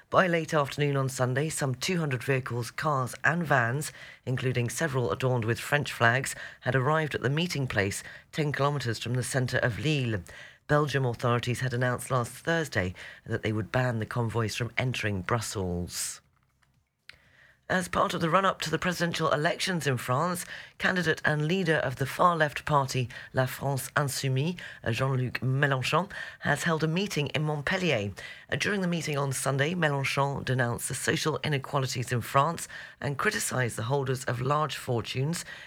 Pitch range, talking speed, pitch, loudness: 120-155 Hz, 155 wpm, 135 Hz, -28 LUFS